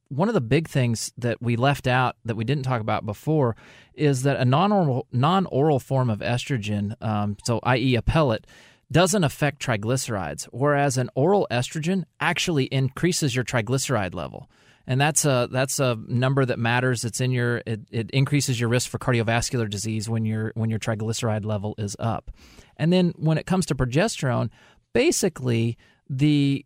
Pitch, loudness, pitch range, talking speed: 125 Hz, -23 LUFS, 115-145 Hz, 175 wpm